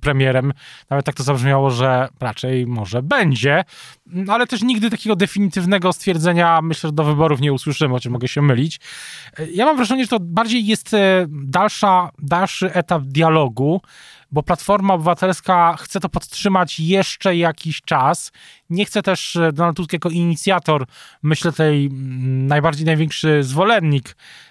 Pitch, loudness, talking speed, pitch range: 165 Hz, -17 LUFS, 140 wpm, 145-185 Hz